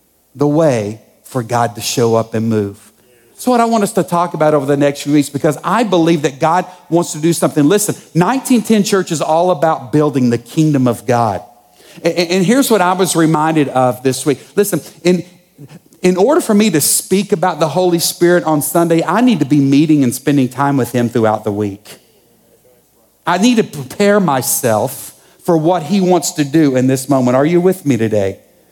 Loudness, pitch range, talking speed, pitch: -13 LUFS, 130-180 Hz, 205 wpm, 155 Hz